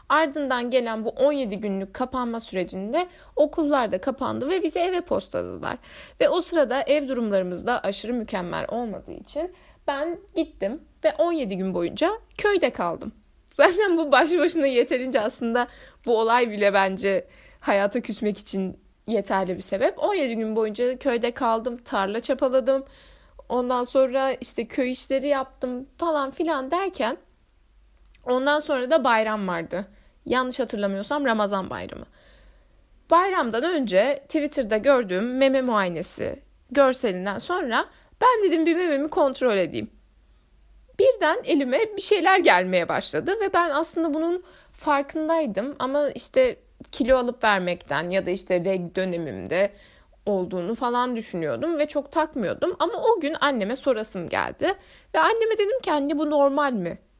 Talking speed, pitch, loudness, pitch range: 135 wpm, 265 Hz, -24 LUFS, 215-310 Hz